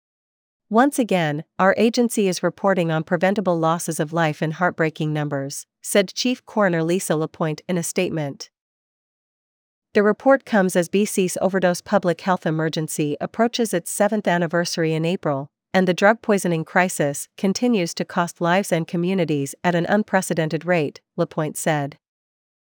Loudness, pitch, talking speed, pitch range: -21 LUFS, 175 Hz, 145 wpm, 160-195 Hz